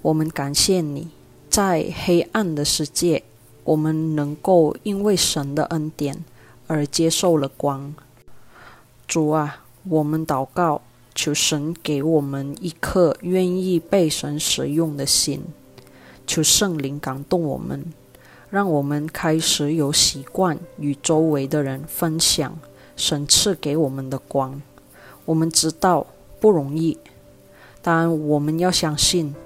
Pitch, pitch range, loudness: 155 Hz, 140-165 Hz, -20 LUFS